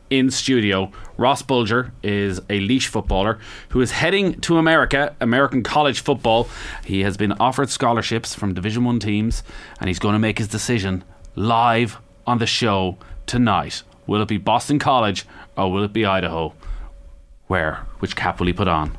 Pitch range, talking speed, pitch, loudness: 95-120 Hz, 170 wpm, 110 Hz, -20 LUFS